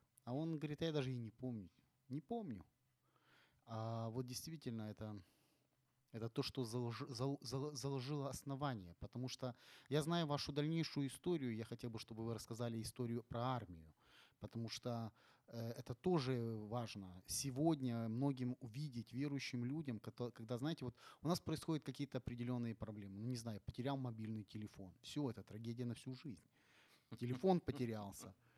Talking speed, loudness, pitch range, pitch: 145 wpm, -45 LUFS, 115-140 Hz, 125 Hz